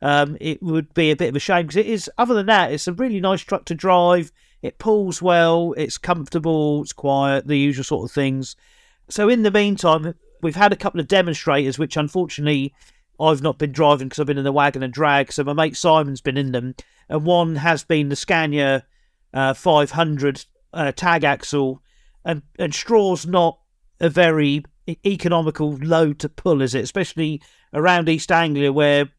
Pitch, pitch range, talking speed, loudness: 155 Hz, 145-175 Hz, 190 wpm, -19 LUFS